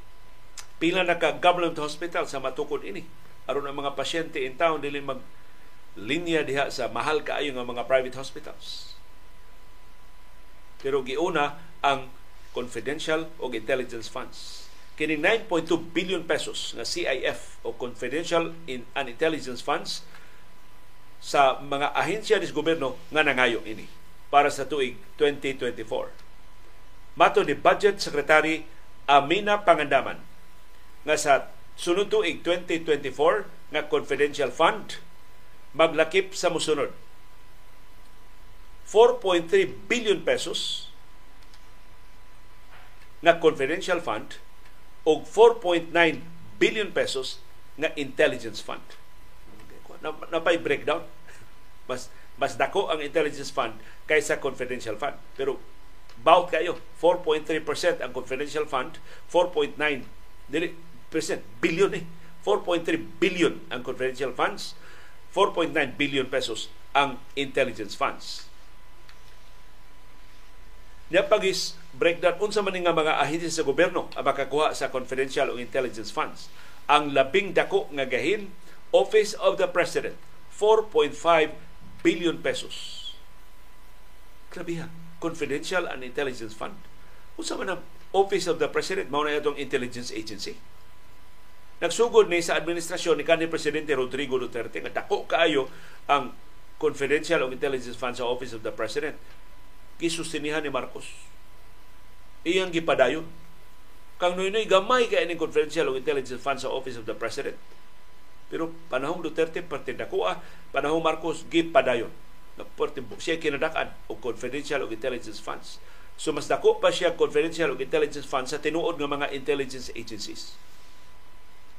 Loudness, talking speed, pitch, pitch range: -26 LUFS, 115 wpm, 155 Hz, 135-190 Hz